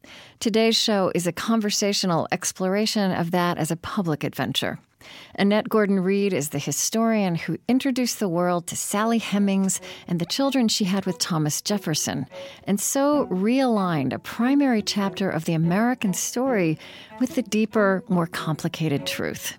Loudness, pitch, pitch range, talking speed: -23 LUFS, 195 Hz, 175-225 Hz, 150 wpm